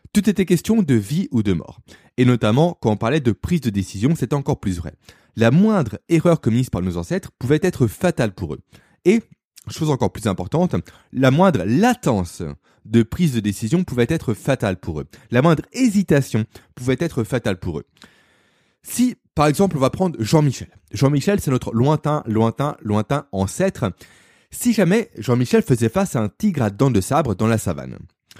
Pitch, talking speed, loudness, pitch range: 125 Hz, 185 wpm, -19 LUFS, 105-165 Hz